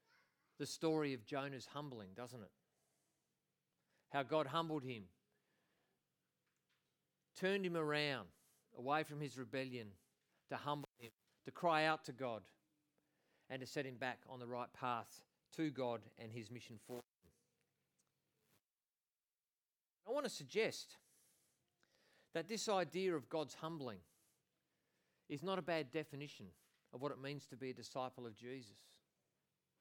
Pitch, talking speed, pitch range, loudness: 135 Hz, 135 wpm, 120-155 Hz, -44 LUFS